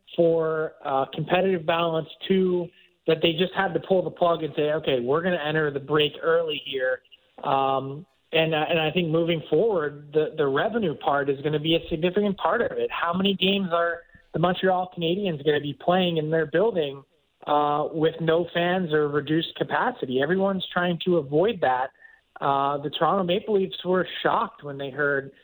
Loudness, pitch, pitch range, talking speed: -24 LUFS, 165 Hz, 150-180 Hz, 190 wpm